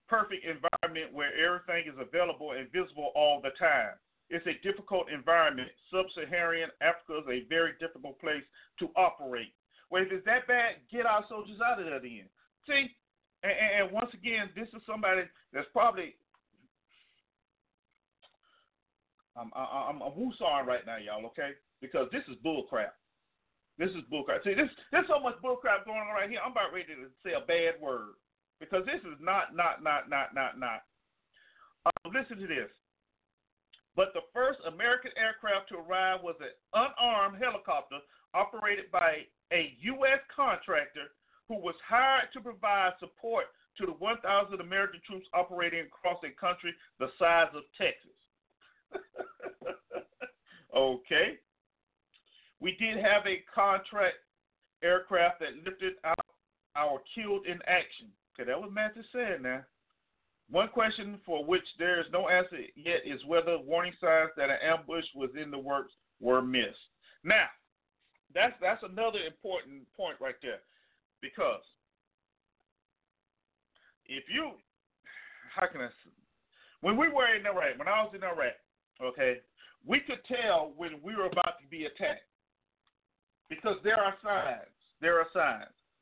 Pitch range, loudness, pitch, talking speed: 165-225 Hz, -31 LUFS, 185 Hz, 150 wpm